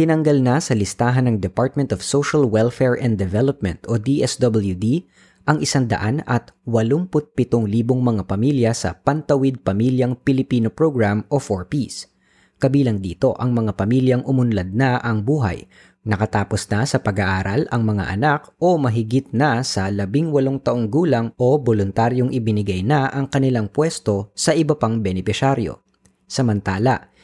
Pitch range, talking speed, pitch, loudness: 105-135 Hz, 135 wpm, 120 Hz, -19 LUFS